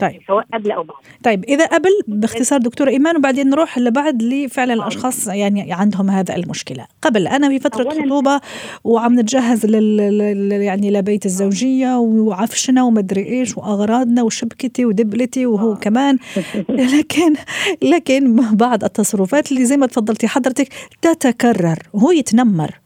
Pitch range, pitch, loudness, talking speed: 210-270 Hz, 240 Hz, -15 LUFS, 120 wpm